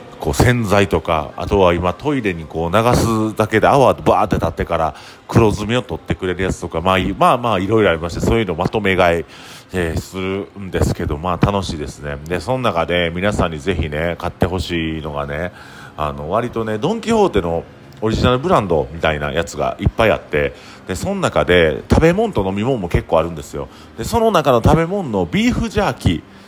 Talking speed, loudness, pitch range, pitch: 420 characters per minute, -17 LUFS, 85-115 Hz, 95 Hz